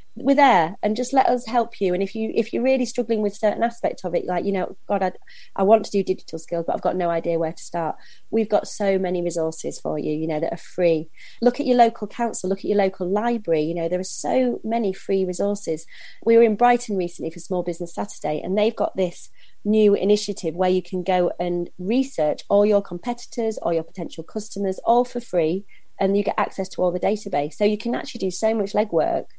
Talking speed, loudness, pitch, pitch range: 235 wpm, -22 LUFS, 195 Hz, 175-225 Hz